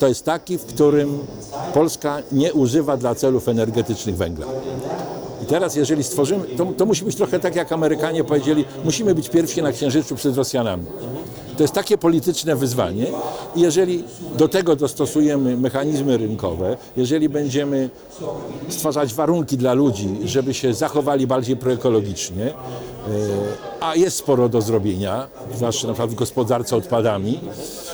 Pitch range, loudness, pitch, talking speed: 125-155 Hz, -20 LUFS, 140 Hz, 140 wpm